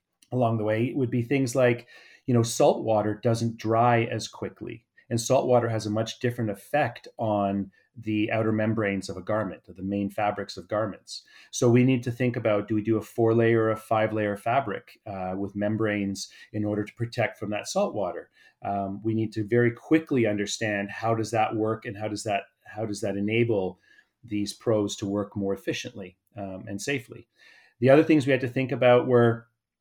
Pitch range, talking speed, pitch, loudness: 105-120 Hz, 205 wpm, 110 Hz, -26 LUFS